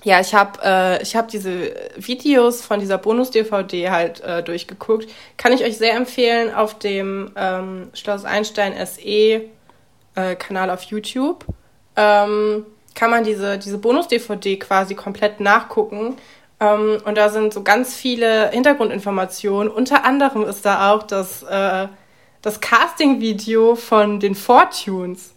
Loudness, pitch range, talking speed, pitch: -18 LUFS, 195-230 Hz, 130 wpm, 210 Hz